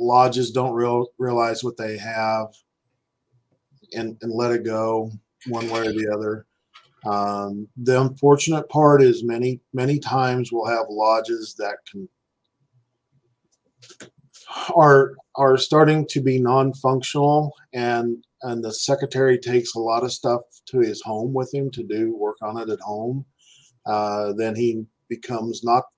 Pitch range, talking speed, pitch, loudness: 115-135 Hz, 145 wpm, 120 Hz, -21 LUFS